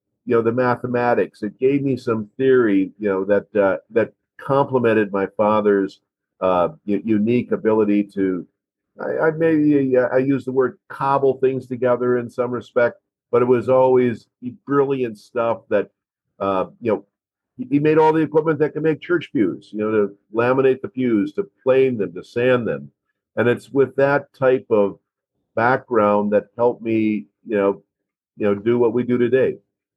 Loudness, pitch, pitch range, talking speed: -19 LUFS, 120 Hz, 105-130 Hz, 175 wpm